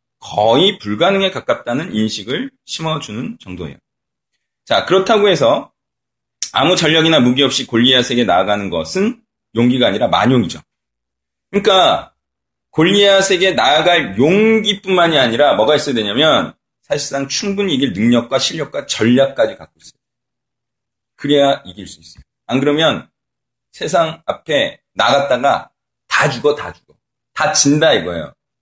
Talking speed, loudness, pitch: 305 characters per minute, -14 LUFS, 135 Hz